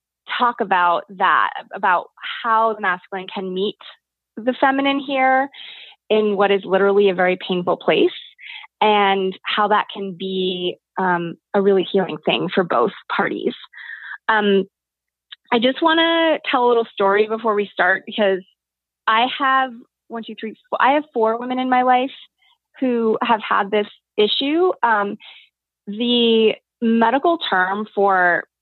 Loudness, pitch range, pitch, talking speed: -18 LUFS, 195-255 Hz, 220 Hz, 145 wpm